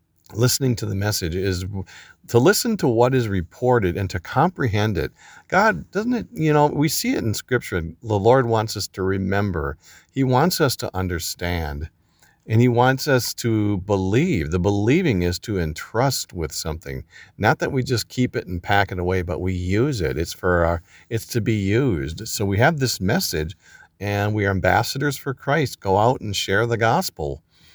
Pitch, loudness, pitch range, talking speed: 105 Hz, -21 LUFS, 90-125 Hz, 190 wpm